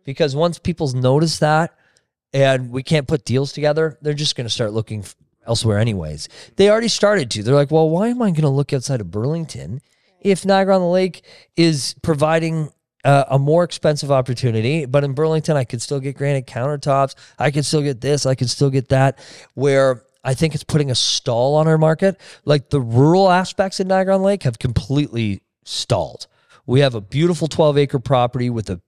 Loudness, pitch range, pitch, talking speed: -18 LUFS, 130-160 Hz, 145 Hz, 200 wpm